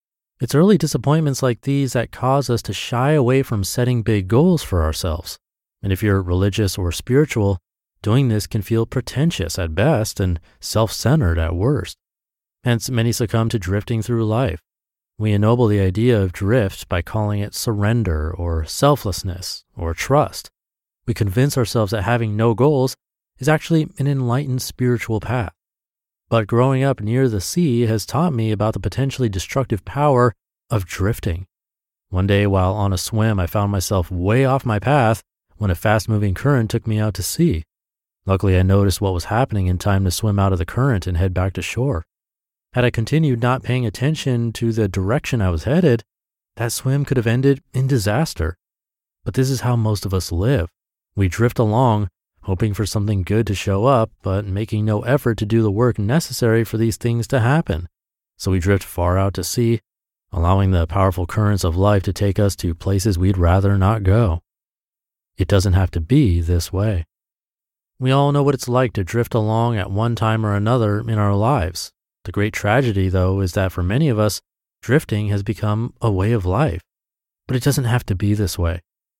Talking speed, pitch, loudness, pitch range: 190 wpm, 110 Hz, -19 LUFS, 95-125 Hz